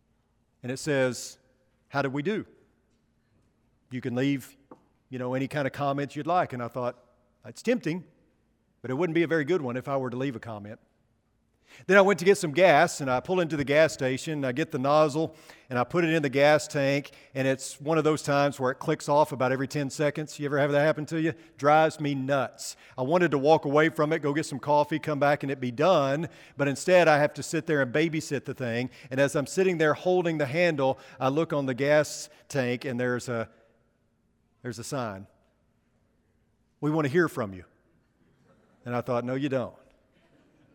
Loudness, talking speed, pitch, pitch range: -26 LUFS, 220 wpm, 140 Hz, 125-155 Hz